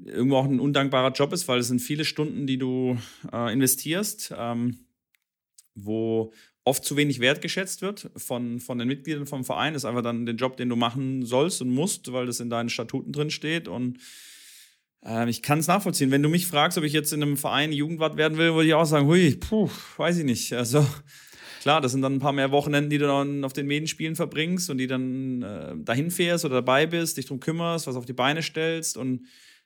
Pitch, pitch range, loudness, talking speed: 140 Hz, 125-155 Hz, -25 LUFS, 225 wpm